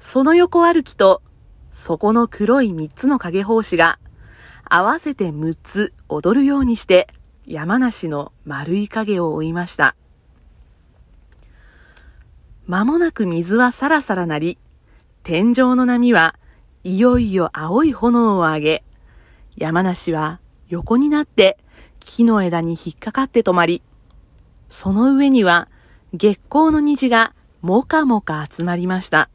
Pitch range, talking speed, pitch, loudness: 170-250 Hz, 225 characters per minute, 200 Hz, -17 LUFS